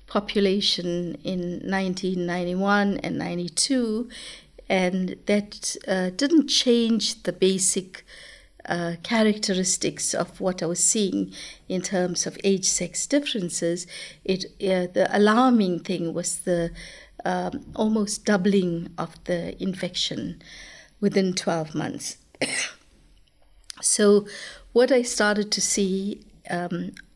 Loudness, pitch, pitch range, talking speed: -24 LUFS, 190 Hz, 175-210 Hz, 105 wpm